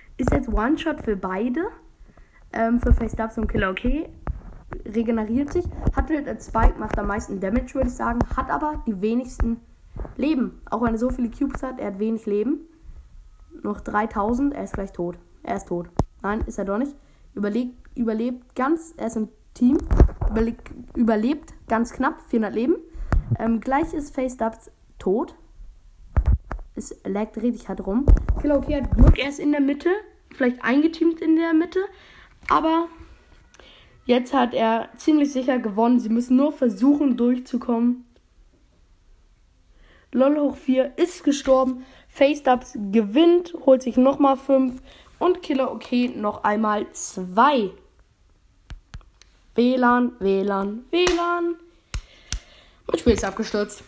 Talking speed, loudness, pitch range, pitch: 140 wpm, -23 LUFS, 220-285 Hz, 245 Hz